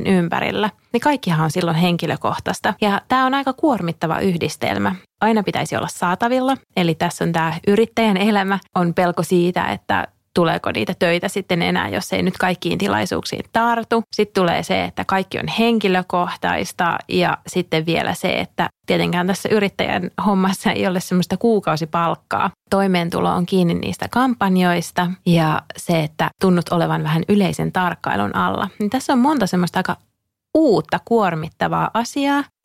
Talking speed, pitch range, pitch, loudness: 145 wpm, 170-215 Hz, 185 Hz, -19 LUFS